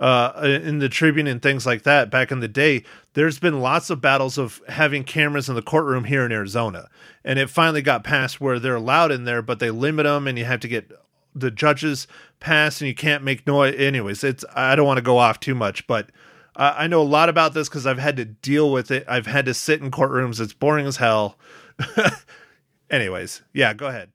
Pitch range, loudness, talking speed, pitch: 125-150 Hz, -20 LUFS, 230 wpm, 135 Hz